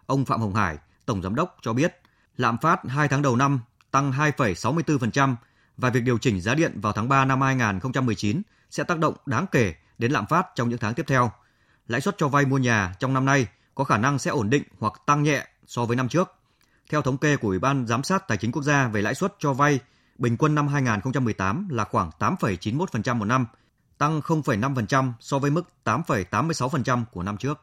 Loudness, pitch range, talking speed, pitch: -24 LUFS, 115-145 Hz, 215 wpm, 130 Hz